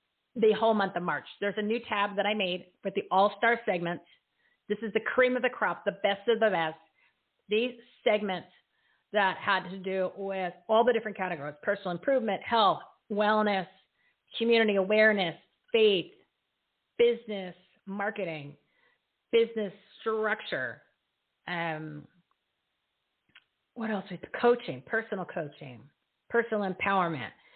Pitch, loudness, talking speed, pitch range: 200 Hz, -29 LUFS, 130 wpm, 180-220 Hz